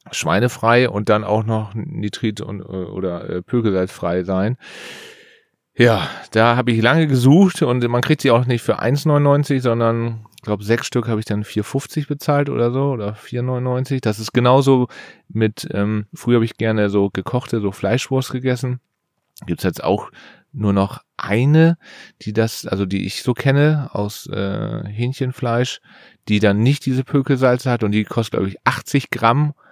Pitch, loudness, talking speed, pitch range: 120 Hz, -18 LUFS, 170 wpm, 105-135 Hz